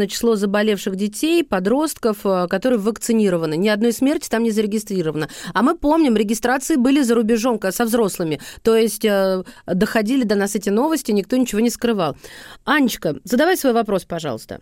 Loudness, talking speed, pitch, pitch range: -19 LUFS, 150 wpm, 225 Hz, 195-250 Hz